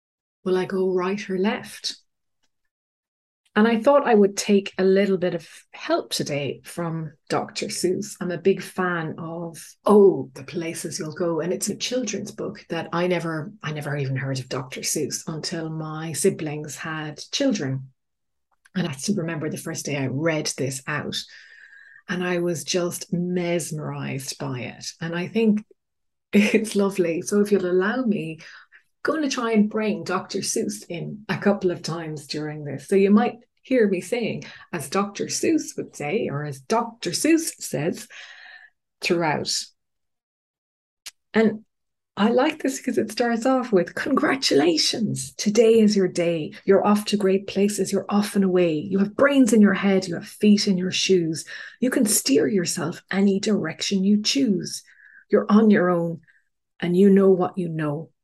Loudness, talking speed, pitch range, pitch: -23 LUFS, 170 wpm, 165-210 Hz, 190 Hz